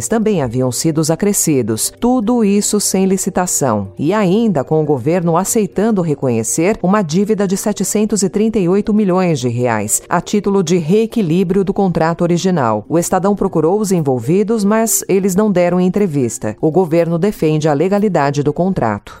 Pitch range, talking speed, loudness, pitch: 160-205 Hz, 145 wpm, -14 LUFS, 185 Hz